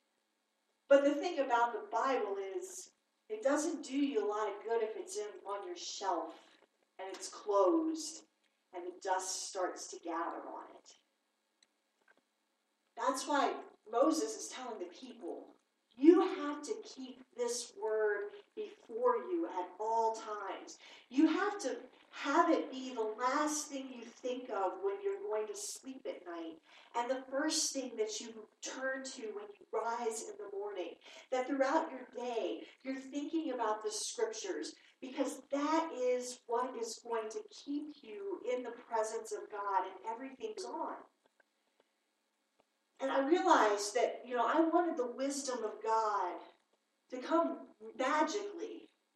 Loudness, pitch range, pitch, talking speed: -36 LUFS, 225-345 Hz, 270 Hz, 150 wpm